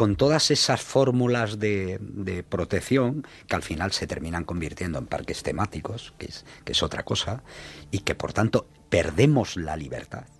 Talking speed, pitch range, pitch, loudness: 165 wpm, 85-125 Hz, 100 Hz, -26 LUFS